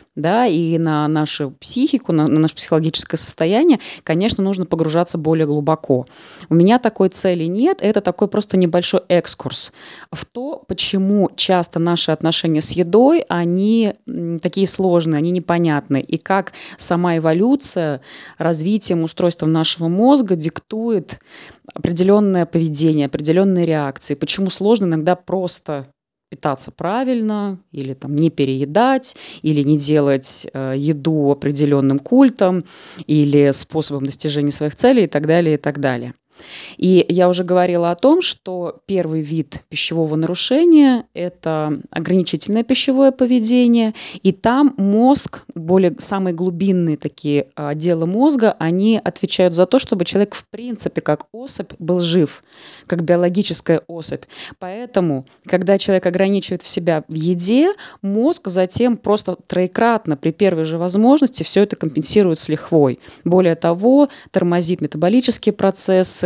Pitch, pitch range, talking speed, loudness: 175 Hz, 160-205 Hz, 130 wpm, -16 LUFS